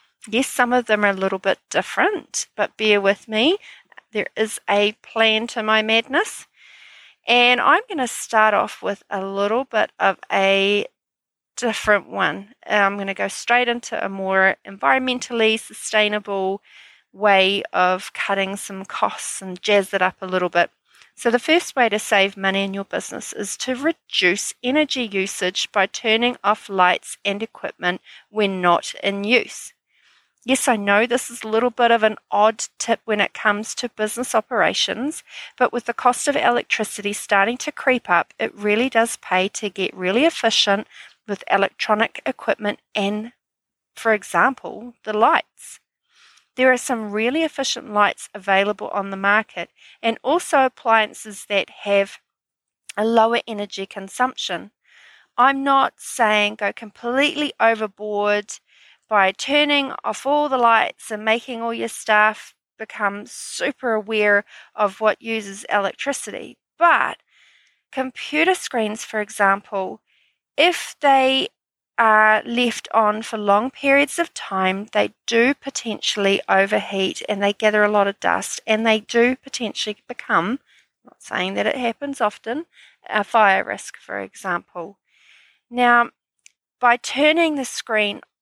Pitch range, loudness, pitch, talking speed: 200-245 Hz, -20 LUFS, 220 Hz, 145 wpm